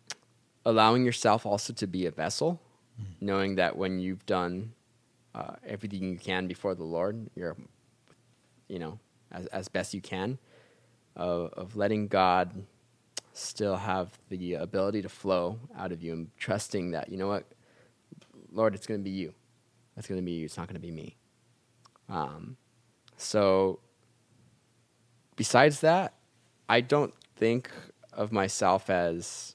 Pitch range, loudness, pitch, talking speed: 95-120 Hz, -30 LUFS, 105 Hz, 150 wpm